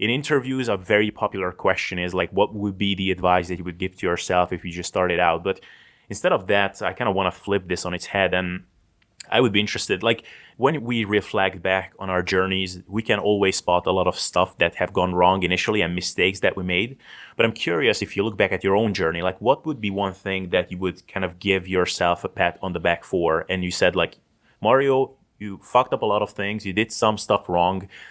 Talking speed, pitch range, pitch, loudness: 250 wpm, 90-105 Hz, 95 Hz, -22 LUFS